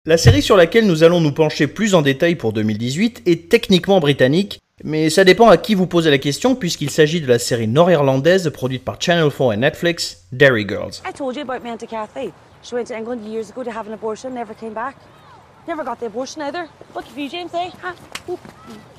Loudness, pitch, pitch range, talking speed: -16 LUFS, 180 Hz, 150-235 Hz, 195 wpm